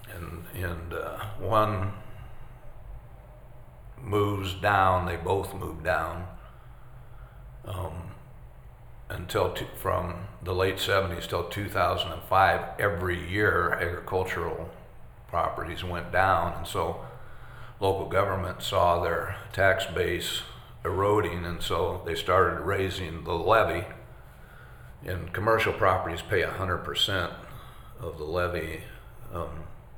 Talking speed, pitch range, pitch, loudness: 100 wpm, 90-115 Hz, 95 Hz, -28 LUFS